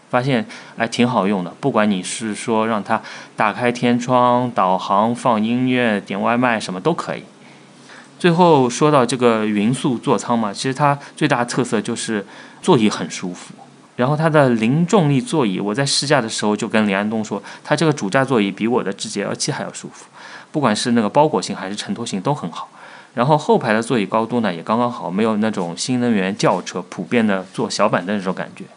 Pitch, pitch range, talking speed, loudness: 120 Hz, 110-135 Hz, 305 characters per minute, -18 LUFS